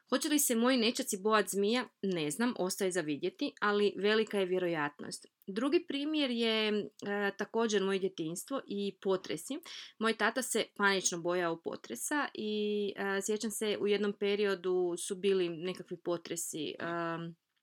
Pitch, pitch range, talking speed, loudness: 205 Hz, 185-225 Hz, 145 wpm, -33 LUFS